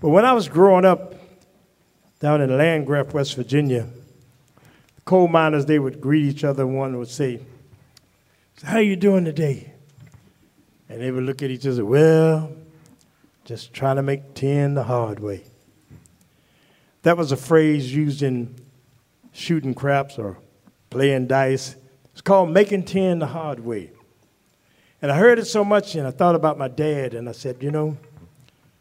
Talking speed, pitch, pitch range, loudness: 165 wpm, 140 Hz, 130-160 Hz, -20 LUFS